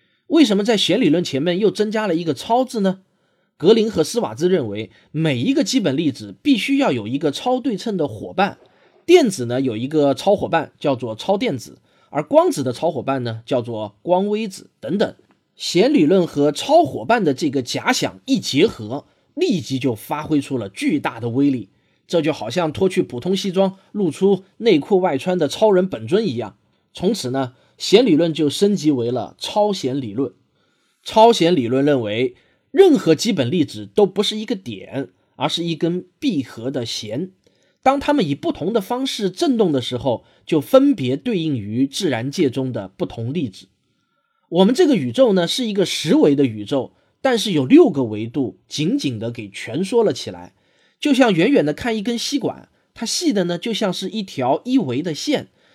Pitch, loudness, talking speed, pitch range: 175 Hz, -19 LUFS, 265 characters per minute, 135-225 Hz